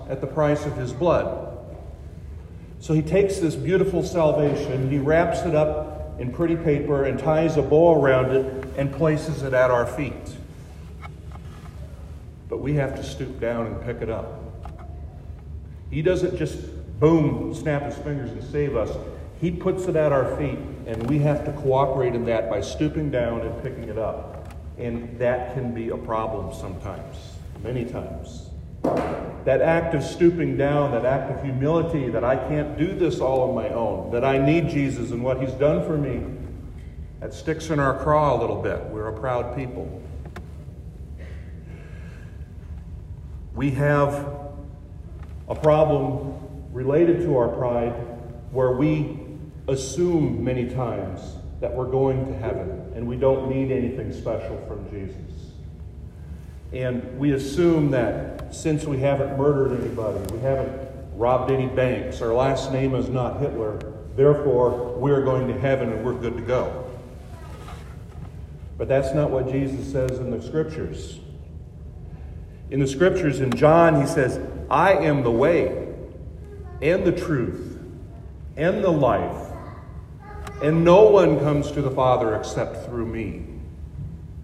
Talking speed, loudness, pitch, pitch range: 150 wpm, -23 LUFS, 125 Hz, 85-145 Hz